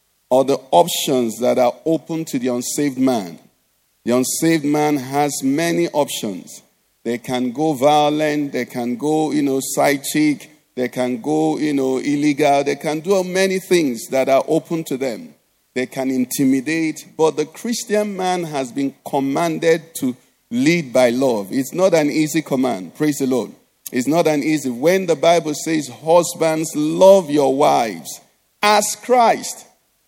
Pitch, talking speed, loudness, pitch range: 150 Hz, 155 wpm, -18 LUFS, 135-165 Hz